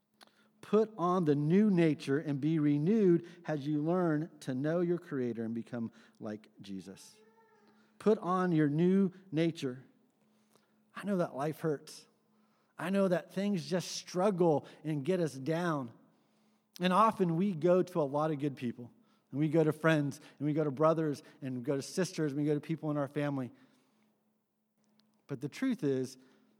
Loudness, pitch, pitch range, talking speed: -32 LUFS, 165 Hz, 145-195 Hz, 170 wpm